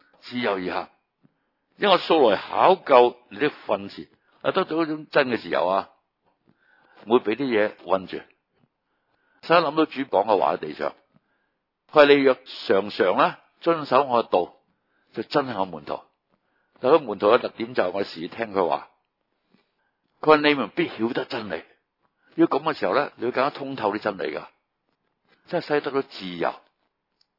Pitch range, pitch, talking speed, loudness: 115-160 Hz, 140 Hz, 230 characters per minute, -23 LUFS